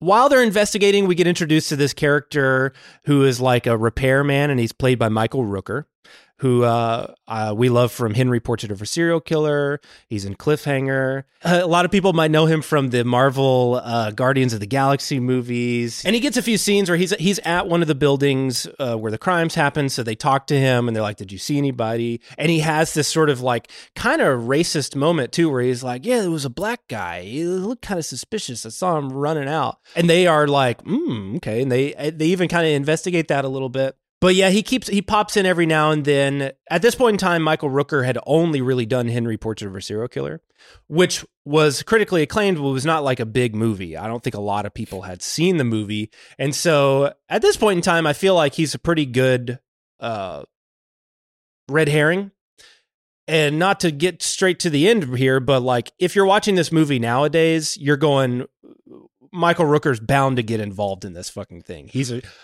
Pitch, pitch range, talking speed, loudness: 140 Hz, 125-170 Hz, 220 wpm, -19 LUFS